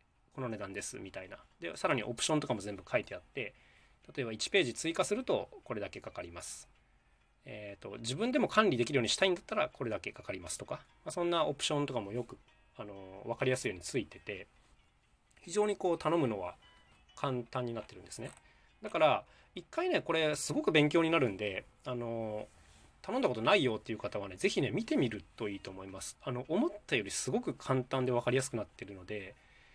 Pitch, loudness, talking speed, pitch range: 125 Hz, -35 LUFS, 420 characters per minute, 105-165 Hz